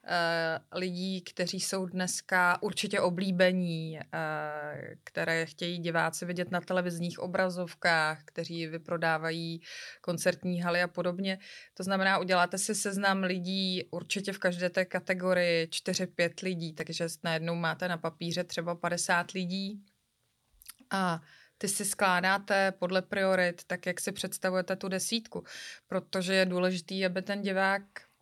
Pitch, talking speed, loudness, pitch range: 180 Hz, 130 wpm, -31 LUFS, 170-190 Hz